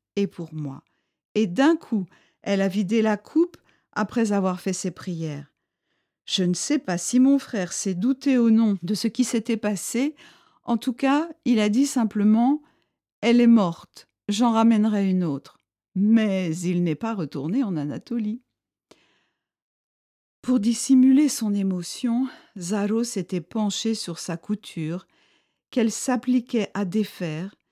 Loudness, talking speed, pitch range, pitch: -23 LUFS, 145 wpm, 185-245 Hz, 215 Hz